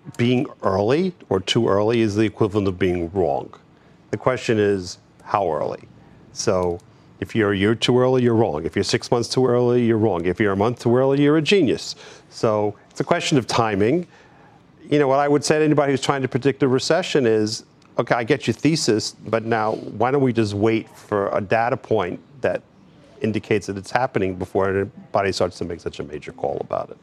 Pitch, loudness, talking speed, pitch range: 120 Hz, -21 LUFS, 210 wpm, 105-140 Hz